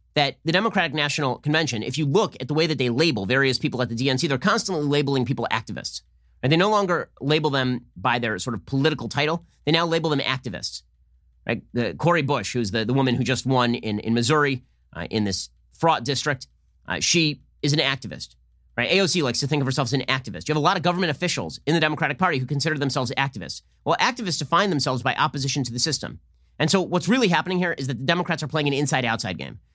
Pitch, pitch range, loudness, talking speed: 140 Hz, 120-160 Hz, -23 LUFS, 230 wpm